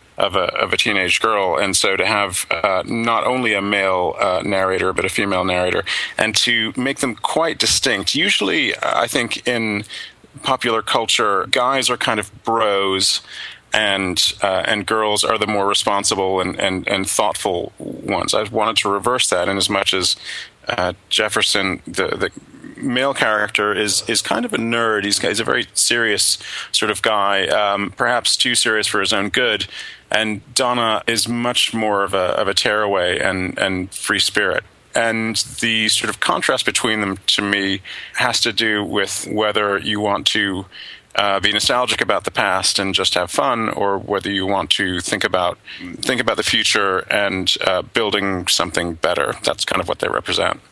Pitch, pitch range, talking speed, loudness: 105 Hz, 95-115 Hz, 180 wpm, -17 LUFS